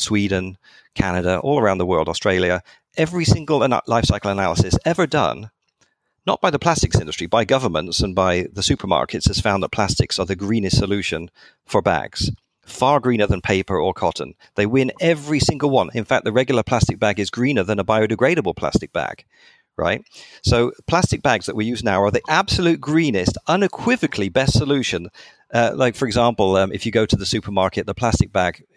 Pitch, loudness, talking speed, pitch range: 115 Hz, -19 LUFS, 185 wpm, 100-130 Hz